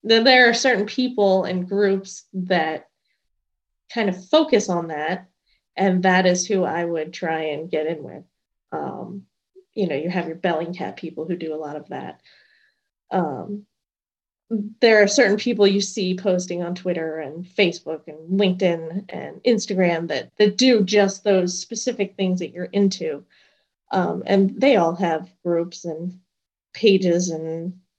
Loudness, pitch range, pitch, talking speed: -21 LUFS, 170-205 Hz, 185 Hz, 155 wpm